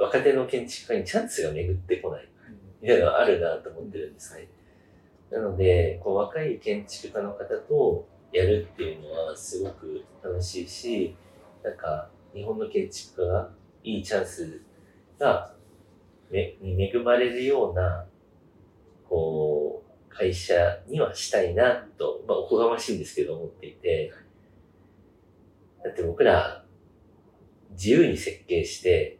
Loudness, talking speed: -26 LUFS, 275 characters per minute